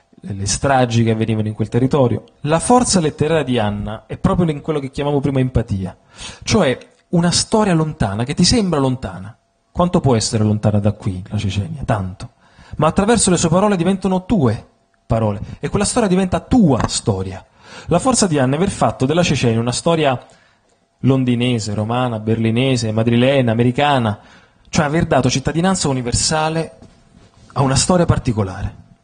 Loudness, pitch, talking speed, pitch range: -17 LUFS, 130 Hz, 155 wpm, 110-165 Hz